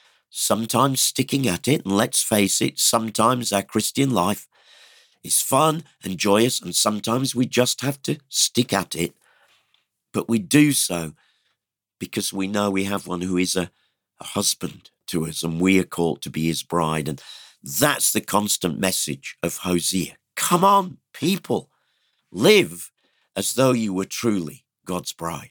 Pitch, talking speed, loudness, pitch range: 100 Hz, 160 wpm, -21 LUFS, 90-125 Hz